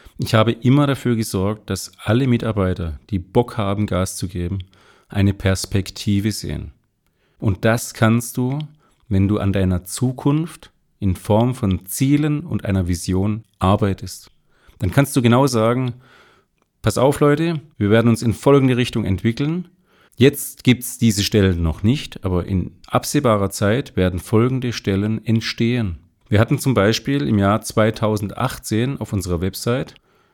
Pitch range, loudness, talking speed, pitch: 95-125 Hz, -19 LUFS, 145 wpm, 110 Hz